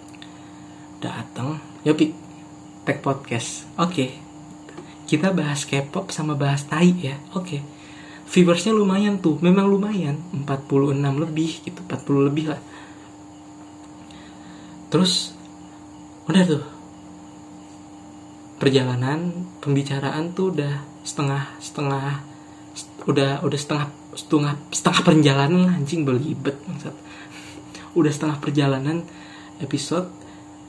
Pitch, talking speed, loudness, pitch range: 145 Hz, 95 wpm, -22 LUFS, 100-155 Hz